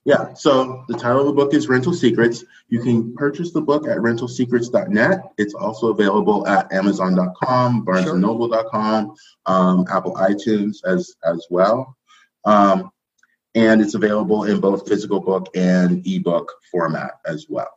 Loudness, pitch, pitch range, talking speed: -18 LUFS, 110 Hz, 95-130 Hz, 145 wpm